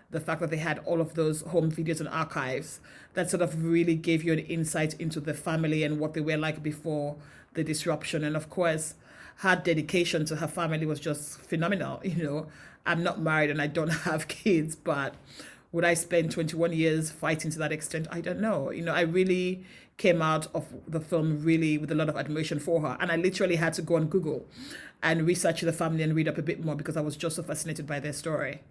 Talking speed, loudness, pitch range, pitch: 230 wpm, -29 LUFS, 155-170 Hz, 160 Hz